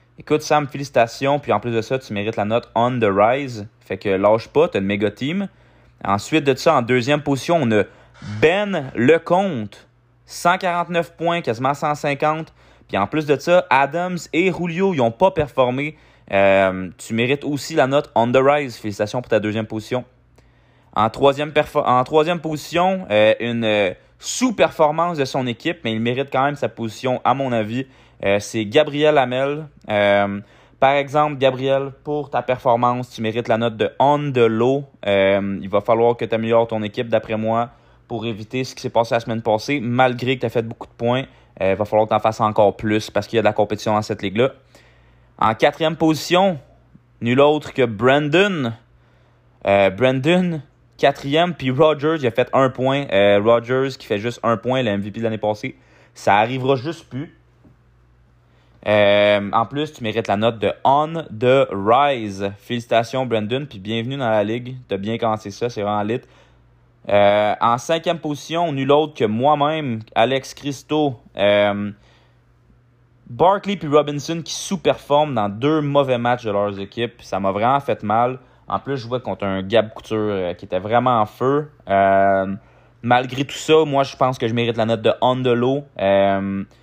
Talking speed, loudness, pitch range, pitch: 185 wpm, -19 LUFS, 110-145 Hz, 120 Hz